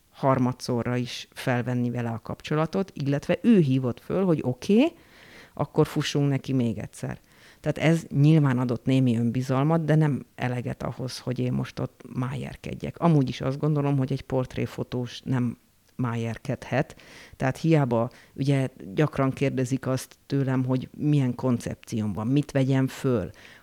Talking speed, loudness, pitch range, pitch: 140 wpm, -26 LUFS, 125-145 Hz, 130 Hz